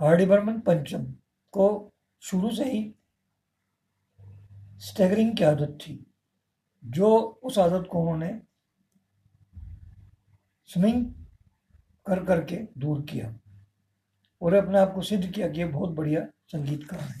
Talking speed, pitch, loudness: 110 wpm, 155 Hz, -26 LUFS